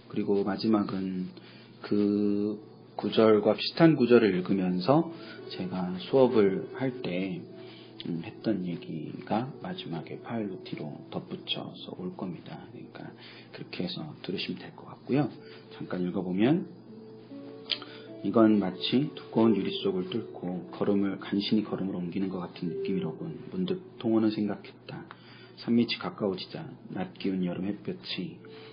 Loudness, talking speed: -29 LUFS, 275 characters per minute